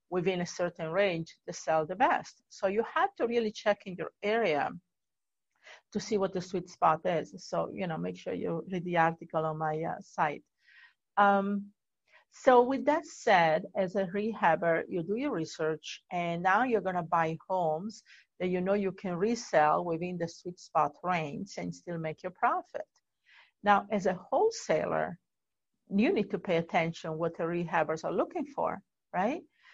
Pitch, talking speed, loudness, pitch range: 185 Hz, 180 wpm, -31 LUFS, 165-210 Hz